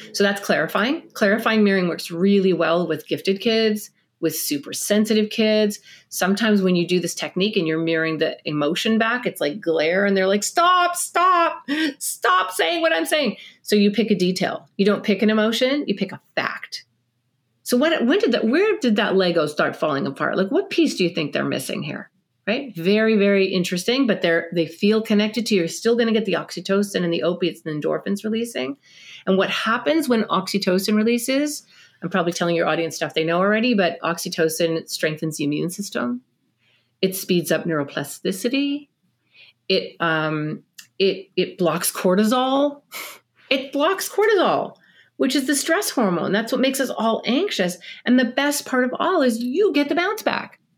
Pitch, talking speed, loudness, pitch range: 200 Hz, 185 wpm, -21 LUFS, 170-250 Hz